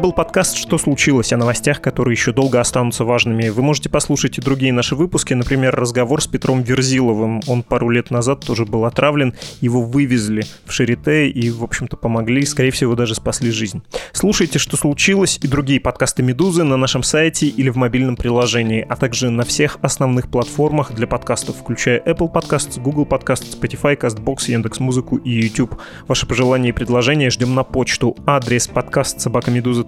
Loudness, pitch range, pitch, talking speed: -17 LUFS, 120-145 Hz, 130 Hz, 170 wpm